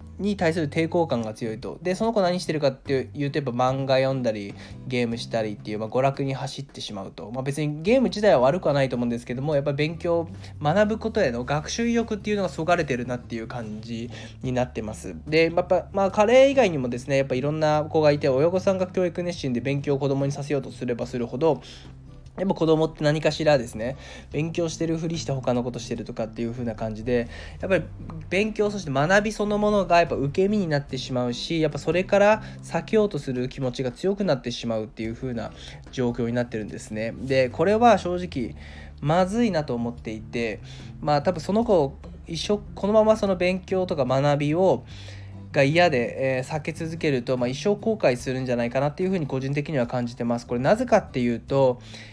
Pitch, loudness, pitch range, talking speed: 140 Hz, -24 LUFS, 120-175 Hz, 435 characters per minute